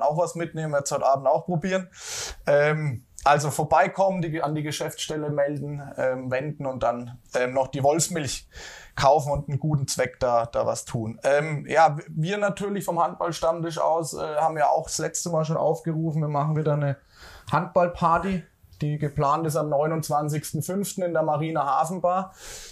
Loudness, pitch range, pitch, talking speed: -25 LUFS, 140-165 Hz, 150 Hz, 170 wpm